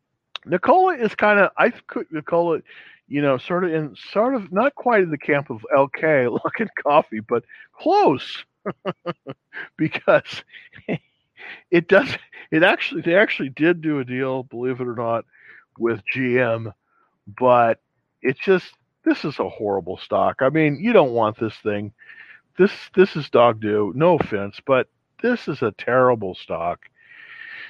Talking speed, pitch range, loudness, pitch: 150 wpm, 120-185 Hz, -20 LUFS, 140 Hz